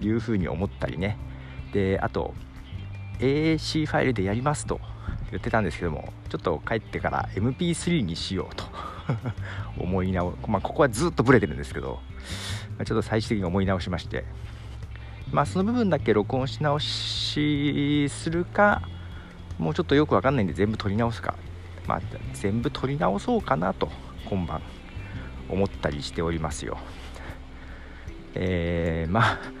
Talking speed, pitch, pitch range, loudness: 315 characters per minute, 100 Hz, 85-115 Hz, -26 LUFS